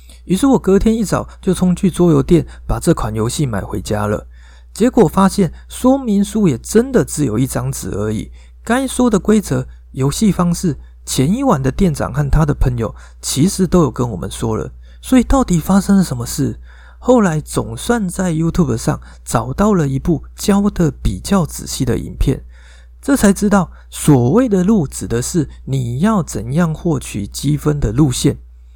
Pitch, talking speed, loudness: 155 Hz, 265 characters per minute, -16 LUFS